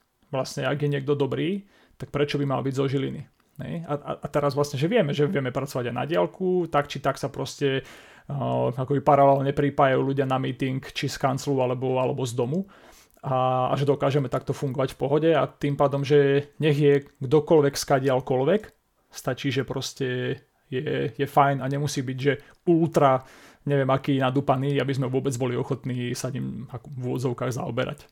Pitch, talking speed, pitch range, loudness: 140 Hz, 175 wpm, 130-145 Hz, -25 LUFS